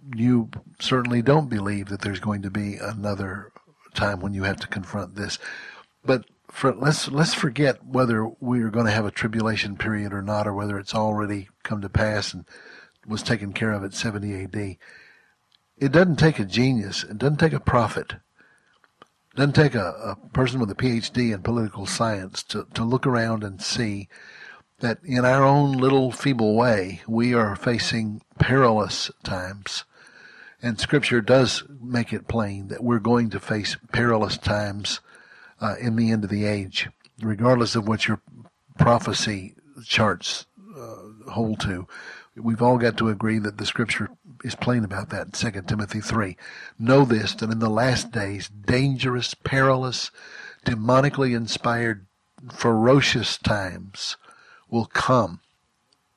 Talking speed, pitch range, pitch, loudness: 155 wpm, 105-125 Hz, 115 Hz, -23 LUFS